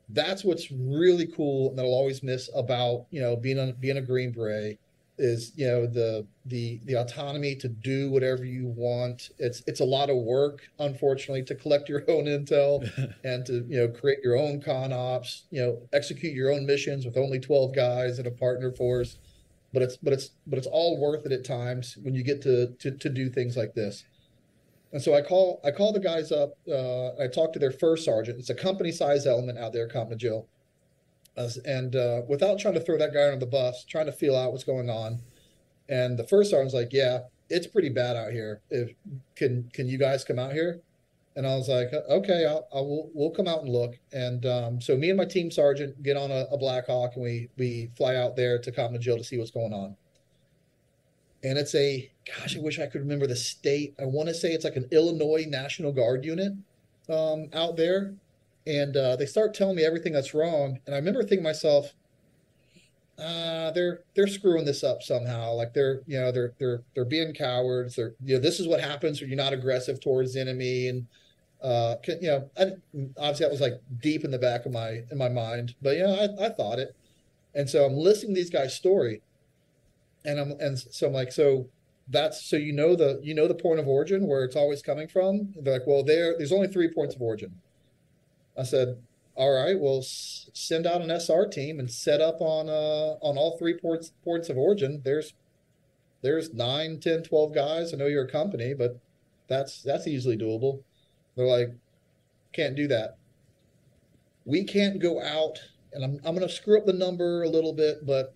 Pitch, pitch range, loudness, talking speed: 140 Hz, 125-155 Hz, -27 LUFS, 210 wpm